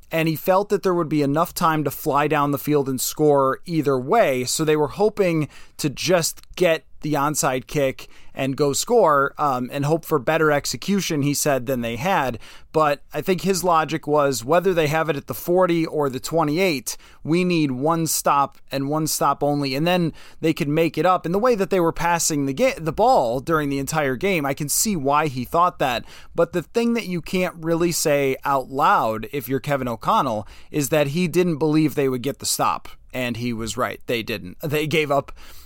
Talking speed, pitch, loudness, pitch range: 215 wpm, 150 Hz, -21 LUFS, 140-170 Hz